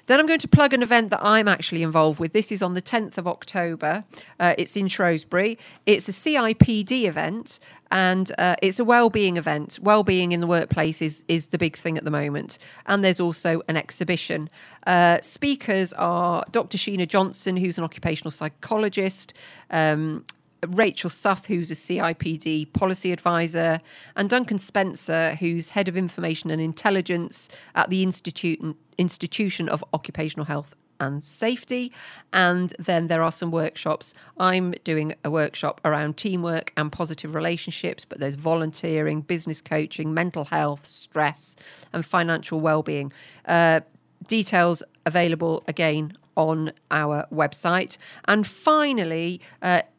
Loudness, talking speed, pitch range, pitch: -23 LUFS, 145 wpm, 160-190 Hz, 170 Hz